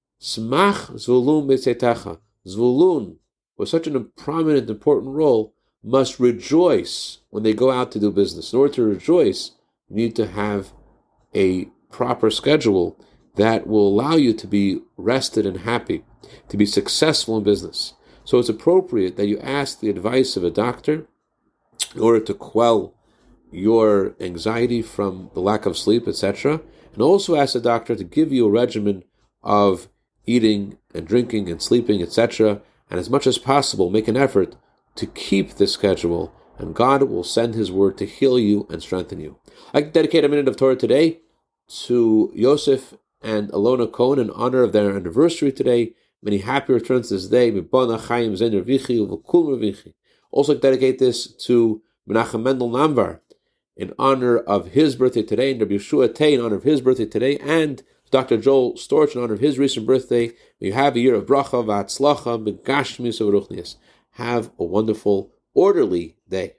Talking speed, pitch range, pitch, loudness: 155 wpm, 105-135 Hz, 120 Hz, -19 LUFS